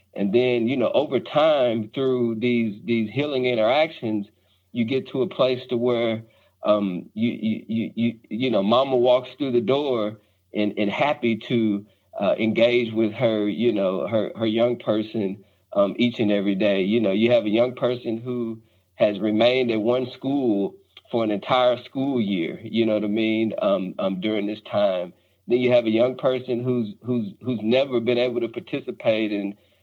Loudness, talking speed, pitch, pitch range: -23 LUFS, 185 wpm, 115 Hz, 105-125 Hz